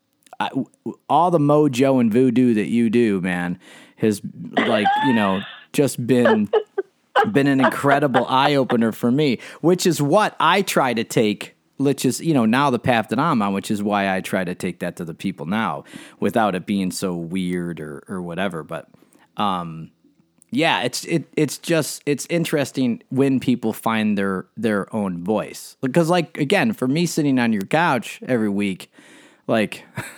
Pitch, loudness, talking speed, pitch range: 130 Hz, -20 LUFS, 175 wpm, 100-150 Hz